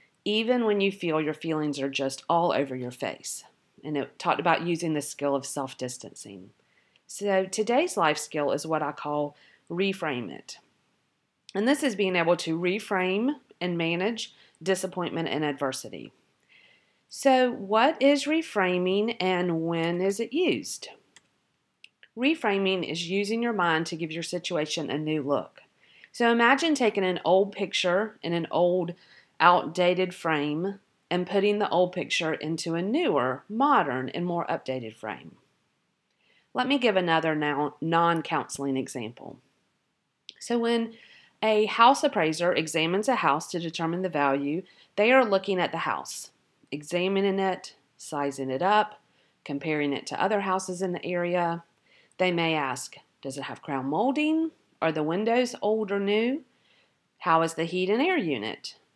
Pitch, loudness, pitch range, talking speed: 180 Hz, -27 LUFS, 155-205 Hz, 150 wpm